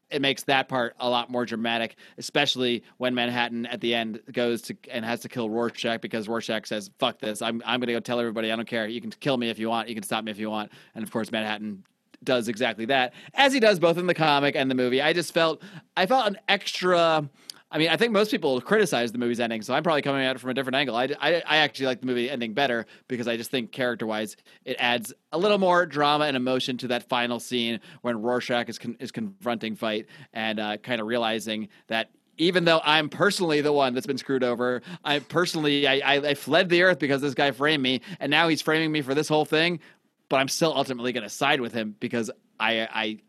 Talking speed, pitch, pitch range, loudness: 245 wpm, 125 Hz, 115-150 Hz, -25 LUFS